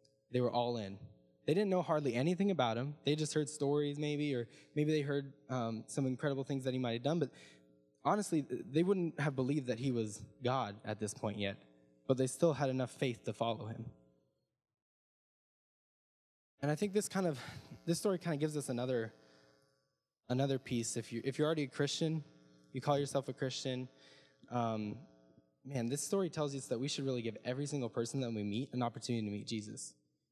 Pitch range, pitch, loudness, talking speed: 115-145 Hz, 130 Hz, -37 LUFS, 200 wpm